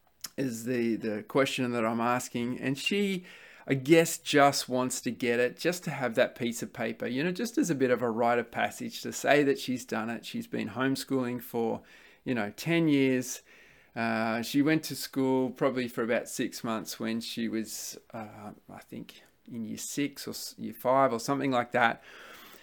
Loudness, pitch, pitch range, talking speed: -30 LUFS, 130 Hz, 120-145 Hz, 195 wpm